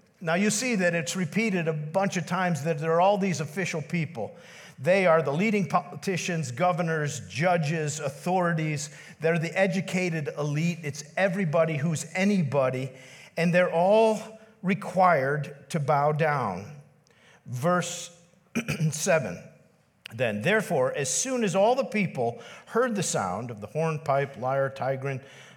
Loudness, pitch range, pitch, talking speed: -26 LUFS, 150-185 Hz, 165 Hz, 135 wpm